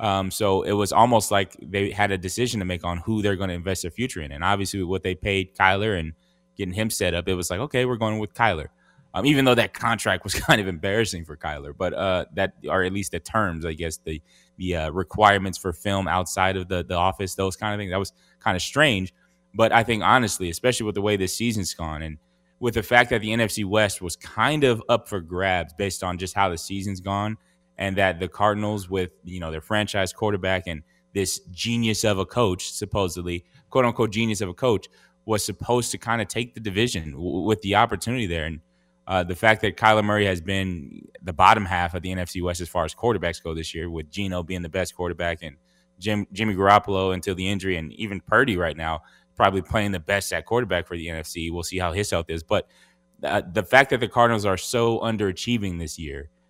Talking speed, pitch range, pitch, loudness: 230 wpm, 90-110 Hz, 95 Hz, -24 LUFS